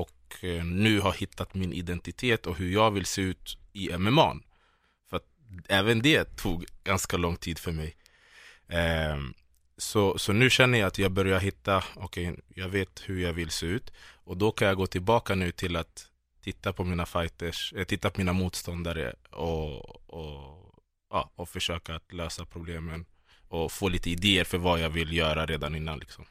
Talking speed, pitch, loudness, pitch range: 185 wpm, 90 Hz, -28 LUFS, 85-95 Hz